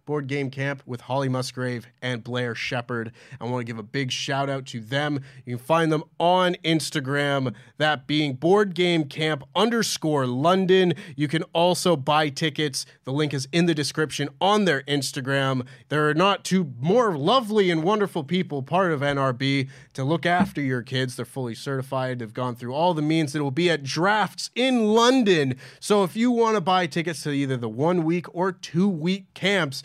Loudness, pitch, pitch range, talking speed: -23 LUFS, 150 Hz, 135-175 Hz, 190 wpm